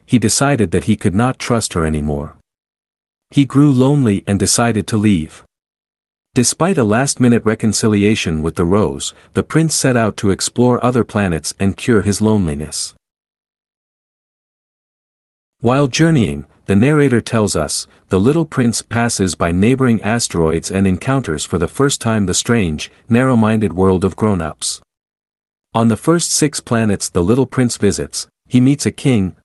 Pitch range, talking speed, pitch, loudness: 95-125 Hz, 155 wpm, 110 Hz, -15 LUFS